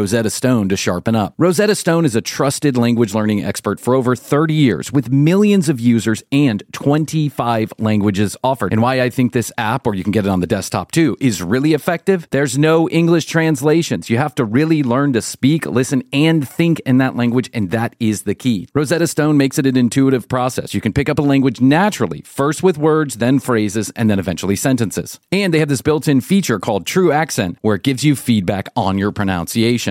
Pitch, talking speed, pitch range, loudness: 130 Hz, 215 wpm, 110-150 Hz, -16 LUFS